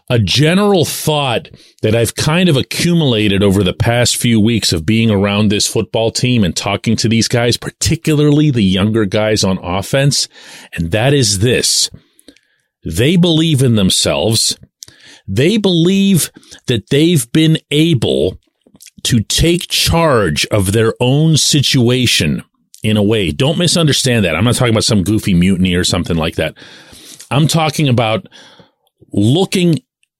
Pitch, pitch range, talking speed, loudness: 120 Hz, 105-150 Hz, 145 wpm, -13 LUFS